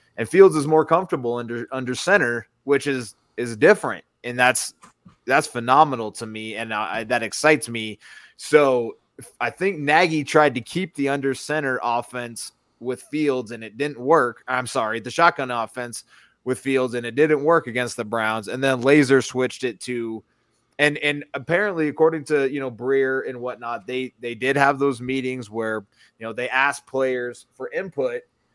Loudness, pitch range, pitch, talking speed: -21 LUFS, 120-145 Hz, 130 Hz, 175 wpm